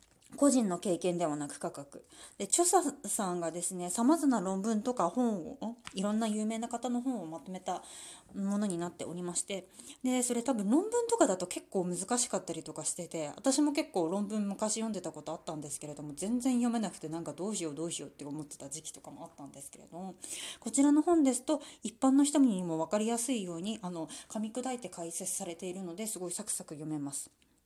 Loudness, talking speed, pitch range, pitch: -33 LUFS, 415 characters per minute, 170-250 Hz, 200 Hz